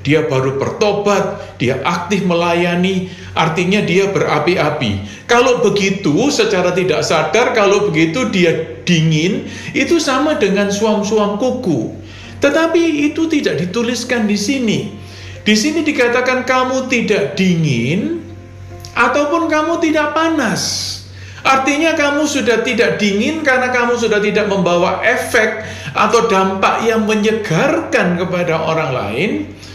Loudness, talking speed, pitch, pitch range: -14 LUFS, 115 wpm, 205 Hz, 165-250 Hz